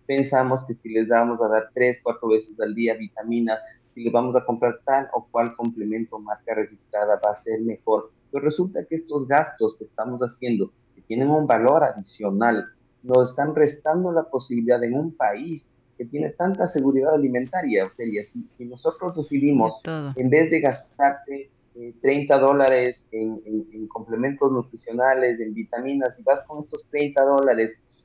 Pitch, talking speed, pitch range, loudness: 125 Hz, 170 wpm, 115-140 Hz, -23 LUFS